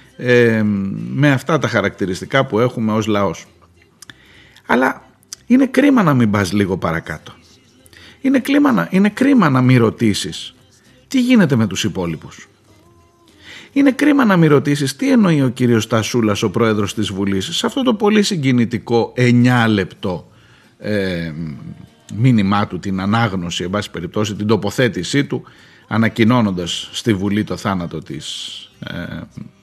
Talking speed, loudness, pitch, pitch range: 140 wpm, -16 LUFS, 115 Hz, 100-140 Hz